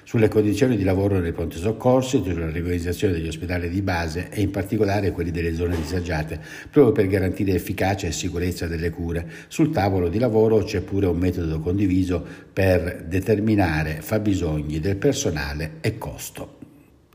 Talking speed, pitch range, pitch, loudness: 155 wpm, 85-105 Hz, 95 Hz, -23 LUFS